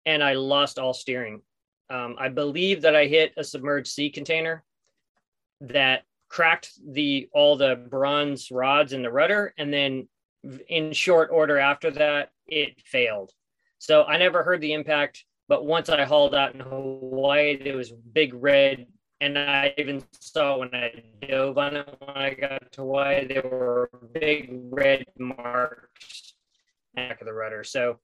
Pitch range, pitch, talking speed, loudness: 130-150 Hz, 140 Hz, 160 wpm, -23 LUFS